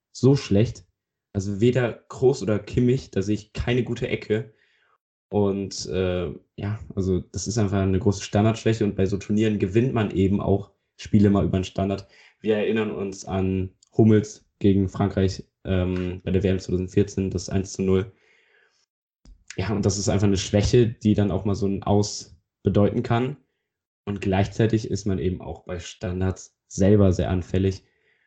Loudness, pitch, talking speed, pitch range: -24 LUFS, 100 Hz, 170 wpm, 95-105 Hz